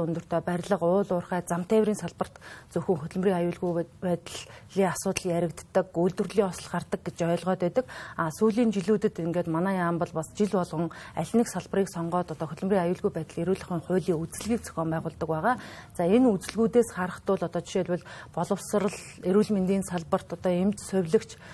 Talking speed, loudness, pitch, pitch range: 160 wpm, -28 LUFS, 180 Hz, 170-200 Hz